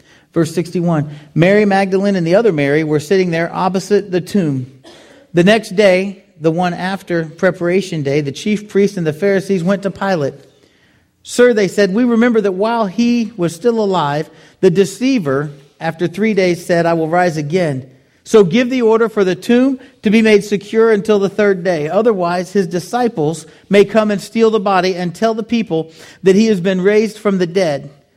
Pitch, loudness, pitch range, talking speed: 190 Hz, -14 LUFS, 165-210 Hz, 185 wpm